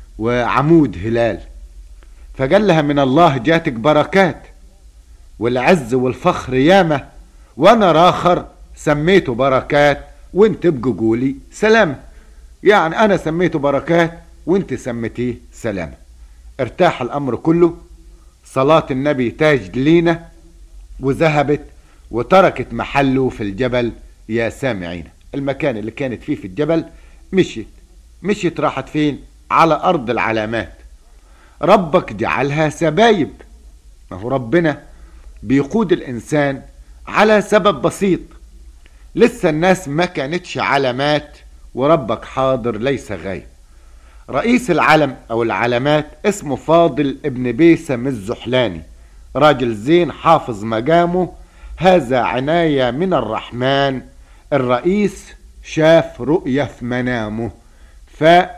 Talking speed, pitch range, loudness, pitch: 100 wpm, 110-165 Hz, -16 LUFS, 135 Hz